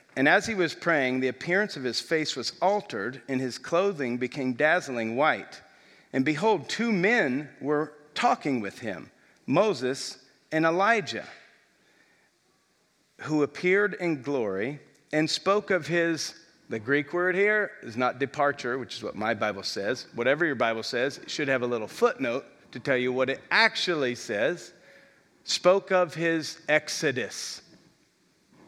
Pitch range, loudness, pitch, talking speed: 130-180 Hz, -27 LUFS, 150 Hz, 150 wpm